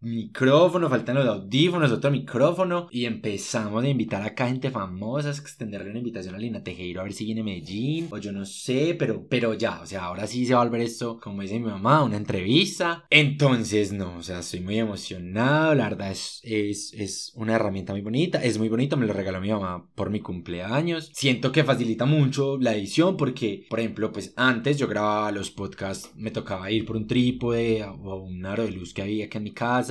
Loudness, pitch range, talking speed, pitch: -25 LUFS, 100-130 Hz, 215 wpm, 115 Hz